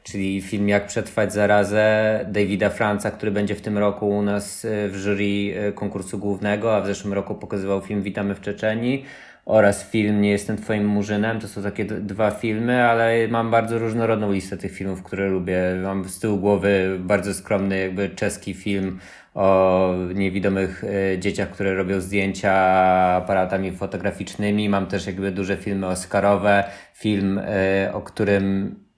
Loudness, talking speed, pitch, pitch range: -22 LUFS, 155 wpm, 100 Hz, 95-105 Hz